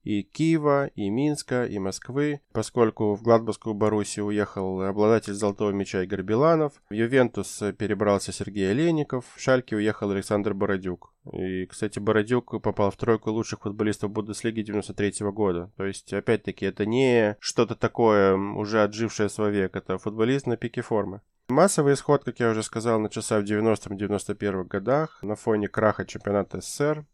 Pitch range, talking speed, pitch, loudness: 100-115 Hz, 155 wpm, 105 Hz, -25 LUFS